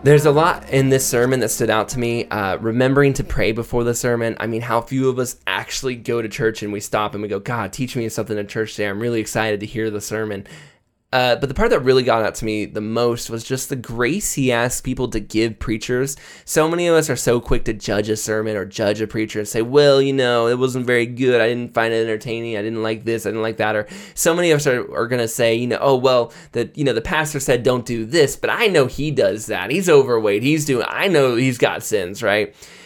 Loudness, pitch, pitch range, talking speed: -19 LUFS, 120 Hz, 110-130 Hz, 270 wpm